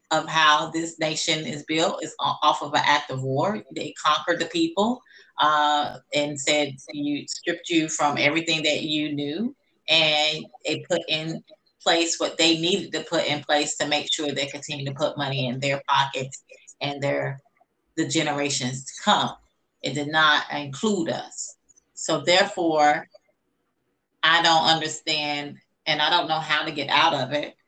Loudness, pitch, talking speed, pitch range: -23 LUFS, 155 Hz, 165 wpm, 145-165 Hz